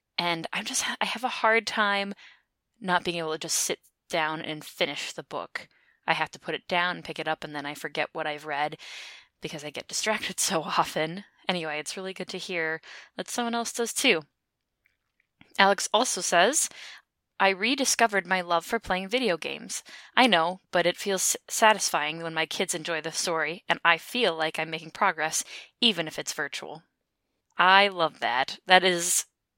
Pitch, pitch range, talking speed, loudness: 175 Hz, 160-200 Hz, 185 wpm, -26 LUFS